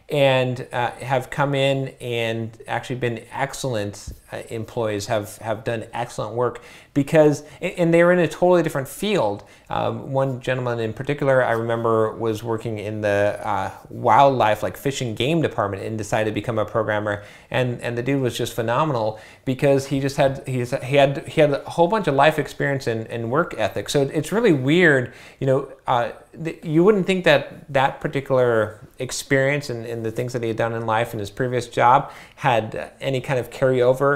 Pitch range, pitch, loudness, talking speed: 115-140 Hz, 130 Hz, -21 LUFS, 185 wpm